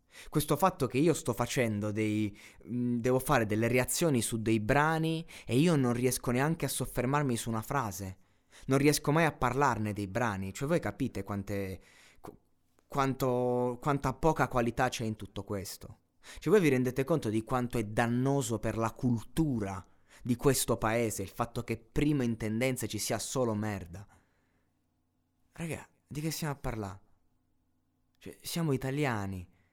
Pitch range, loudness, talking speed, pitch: 100-135 Hz, -31 LUFS, 155 wpm, 120 Hz